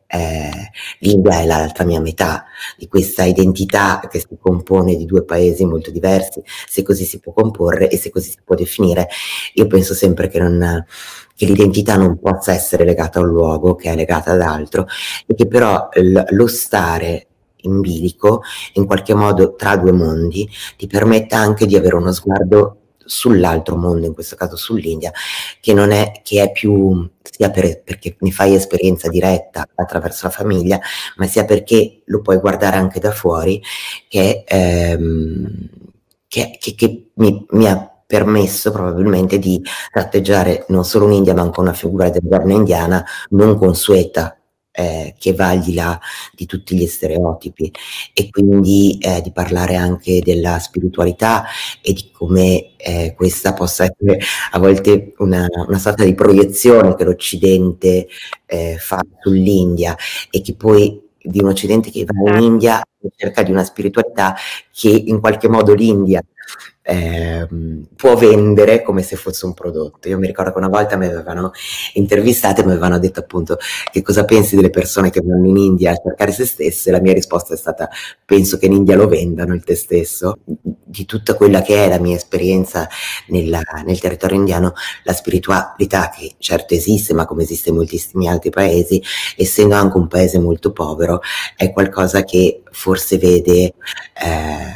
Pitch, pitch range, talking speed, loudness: 95 Hz, 90-100 Hz, 170 wpm, -14 LUFS